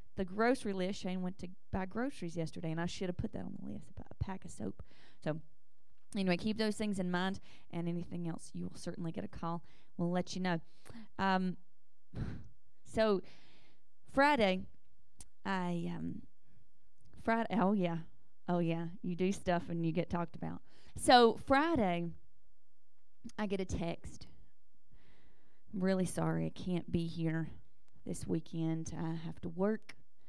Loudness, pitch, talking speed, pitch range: -36 LUFS, 180 Hz, 160 wpm, 170-195 Hz